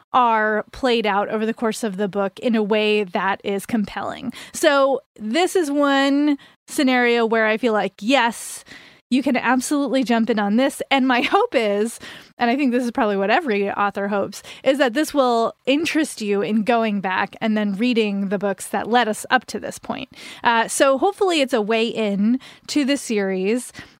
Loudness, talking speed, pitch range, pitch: -20 LUFS, 195 wpm, 210-270 Hz, 235 Hz